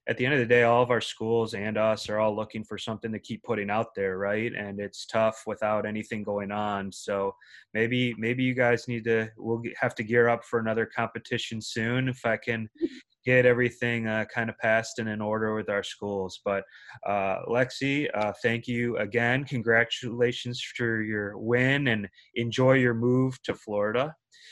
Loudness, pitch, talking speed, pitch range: -27 LUFS, 115 Hz, 190 wpm, 110-120 Hz